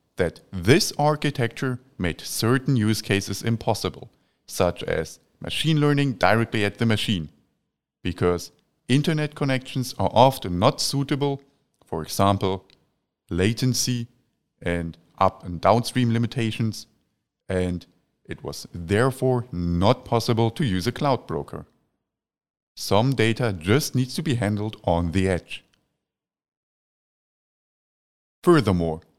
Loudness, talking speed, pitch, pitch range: -23 LUFS, 110 wpm, 115 Hz, 95-130 Hz